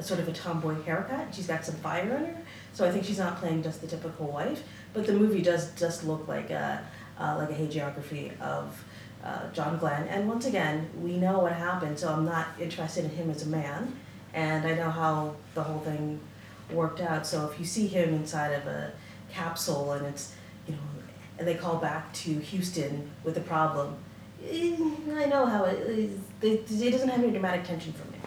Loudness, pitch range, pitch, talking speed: -31 LUFS, 155-185 Hz, 165 Hz, 205 wpm